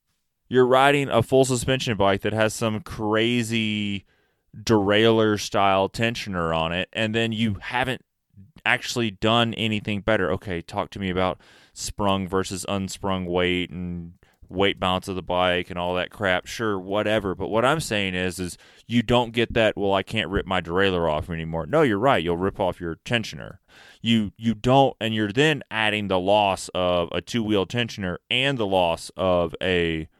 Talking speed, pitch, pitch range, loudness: 175 wpm, 100 Hz, 90-110 Hz, -23 LUFS